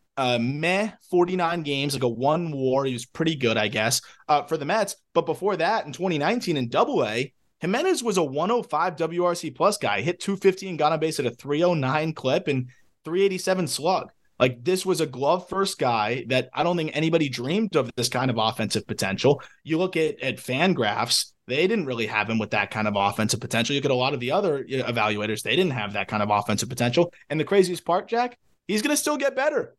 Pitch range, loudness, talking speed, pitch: 125-180 Hz, -24 LUFS, 235 wpm, 150 Hz